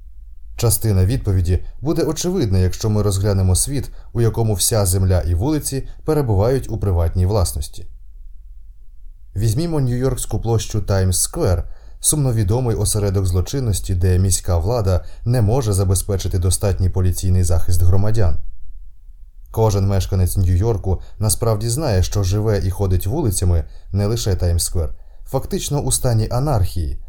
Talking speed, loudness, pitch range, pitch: 120 wpm, -19 LUFS, 90-115 Hz, 100 Hz